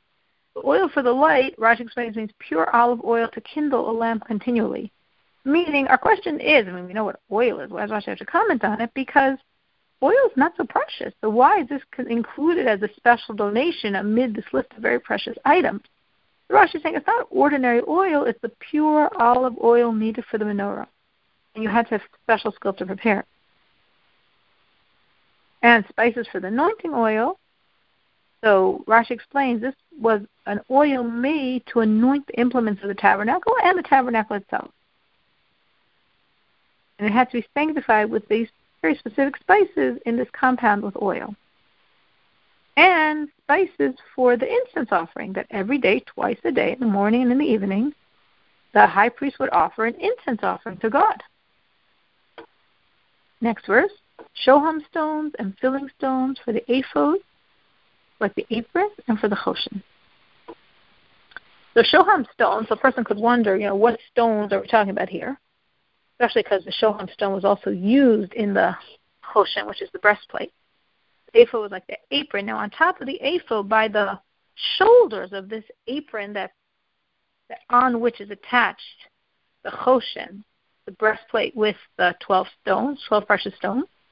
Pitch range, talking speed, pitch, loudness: 215-285 Hz, 170 wpm, 235 Hz, -21 LUFS